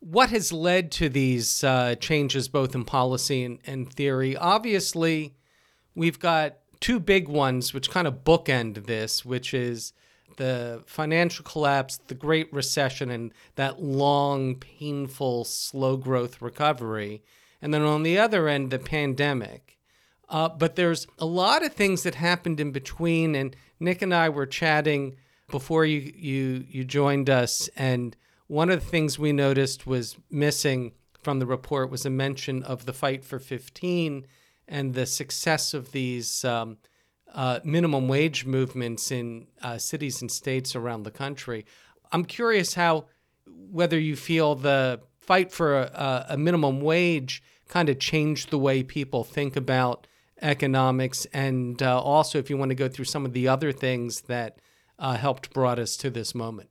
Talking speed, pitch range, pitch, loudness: 160 wpm, 130-155 Hz, 140 Hz, -26 LUFS